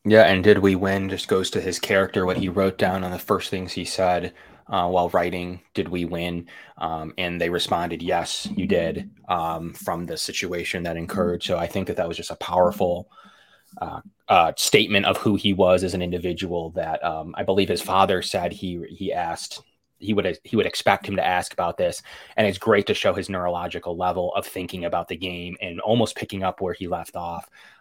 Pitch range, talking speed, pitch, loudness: 85-95 Hz, 215 wpm, 90 Hz, -23 LUFS